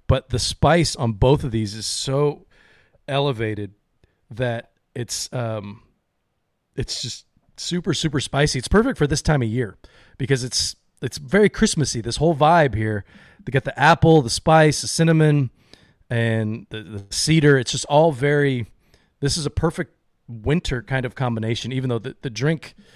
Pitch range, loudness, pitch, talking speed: 115-150 Hz, -20 LUFS, 130 Hz, 160 wpm